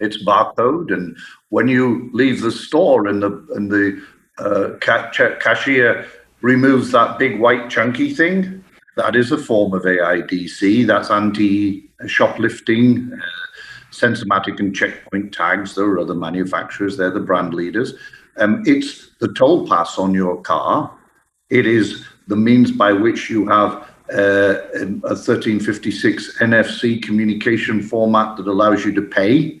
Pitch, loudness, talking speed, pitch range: 105 Hz, -16 LUFS, 140 wpm, 100-125 Hz